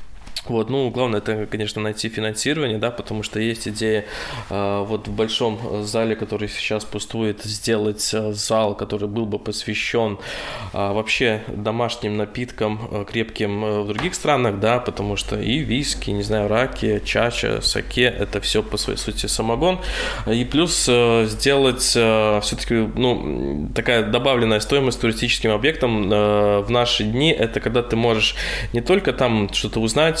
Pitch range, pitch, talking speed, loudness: 105-120 Hz, 110 Hz, 155 wpm, -21 LUFS